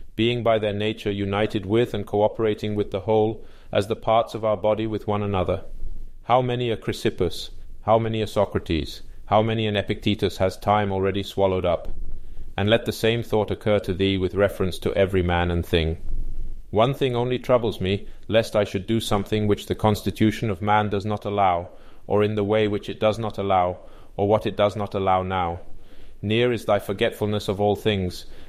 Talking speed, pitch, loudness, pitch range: 195 wpm, 105 Hz, -23 LUFS, 100-110 Hz